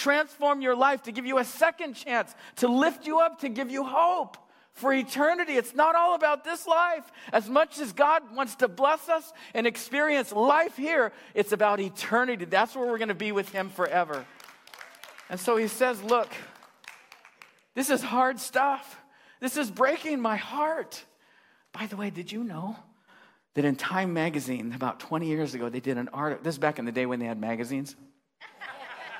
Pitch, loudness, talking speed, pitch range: 245 Hz, -27 LUFS, 185 wpm, 195-290 Hz